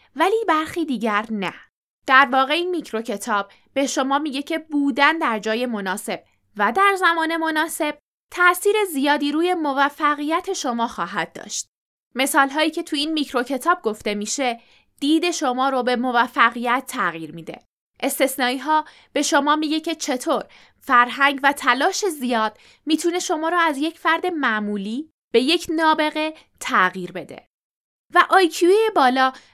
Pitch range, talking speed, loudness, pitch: 245-320 Hz, 140 wpm, -20 LUFS, 285 Hz